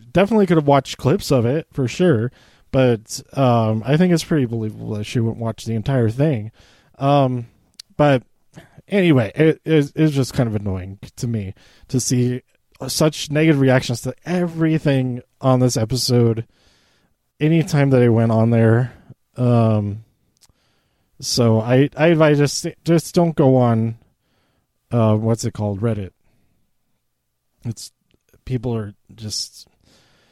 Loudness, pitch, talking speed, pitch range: -18 LUFS, 125 Hz, 140 wpm, 115-145 Hz